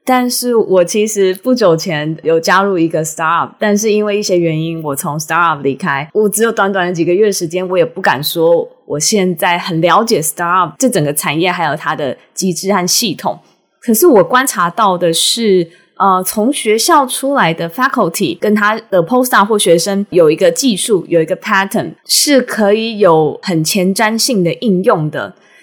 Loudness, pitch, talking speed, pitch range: -12 LUFS, 190 Hz, 335 characters per minute, 170-220 Hz